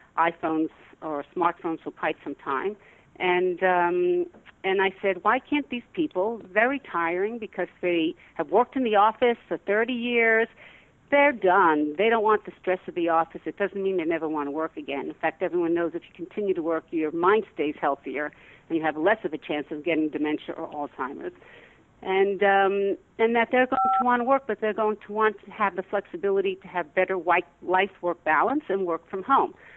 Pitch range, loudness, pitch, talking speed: 165-215 Hz, -25 LUFS, 190 Hz, 200 wpm